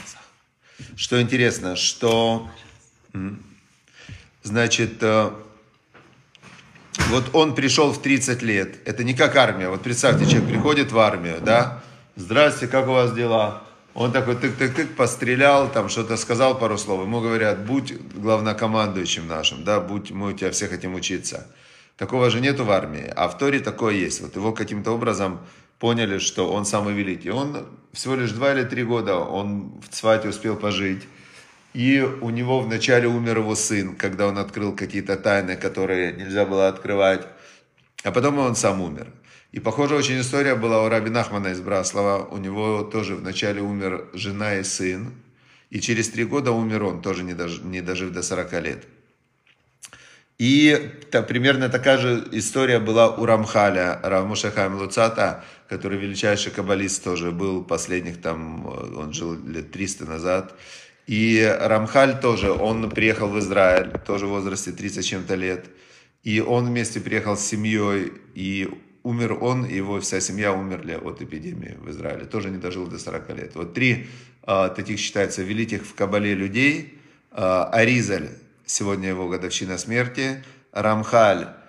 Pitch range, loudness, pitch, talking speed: 95-120 Hz, -22 LUFS, 105 Hz, 150 wpm